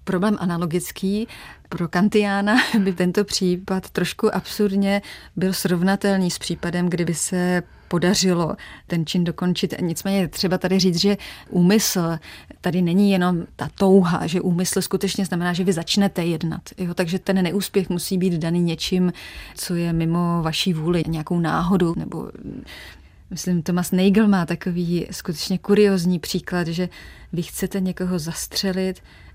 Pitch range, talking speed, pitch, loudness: 175-195 Hz, 140 wpm, 180 Hz, -21 LUFS